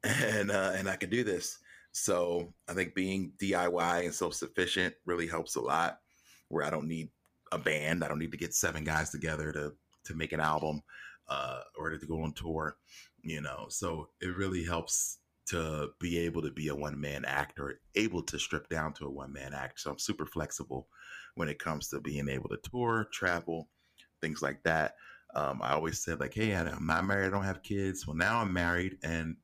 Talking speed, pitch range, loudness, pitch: 210 wpm, 75-90 Hz, -34 LUFS, 80 Hz